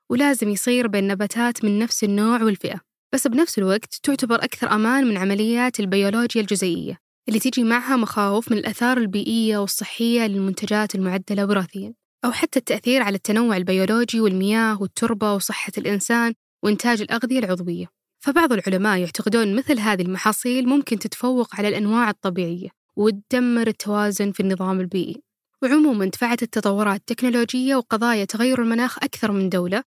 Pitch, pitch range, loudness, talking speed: 220 Hz, 200-240 Hz, -21 LUFS, 135 wpm